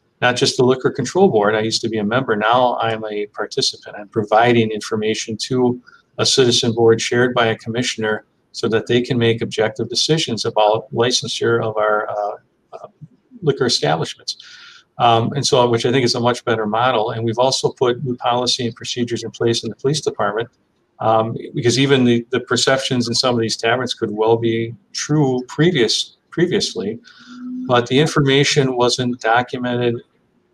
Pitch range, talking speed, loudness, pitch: 115-125 Hz, 175 wpm, -17 LUFS, 120 Hz